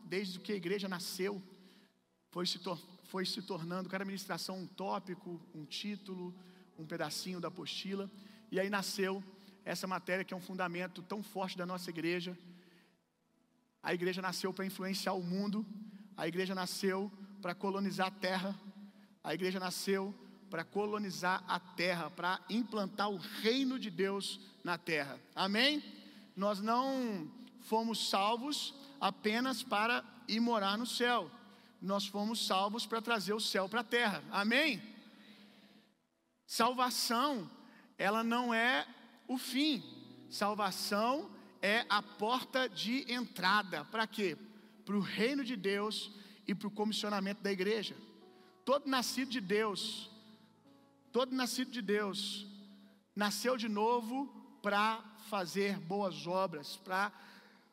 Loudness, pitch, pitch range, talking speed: -36 LUFS, 205 Hz, 190-225 Hz, 130 wpm